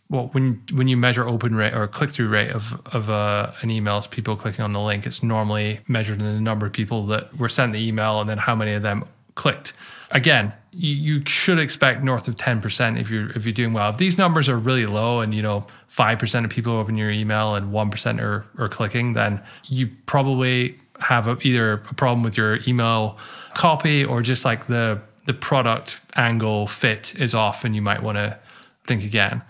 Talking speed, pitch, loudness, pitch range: 220 wpm, 115 Hz, -21 LUFS, 105-125 Hz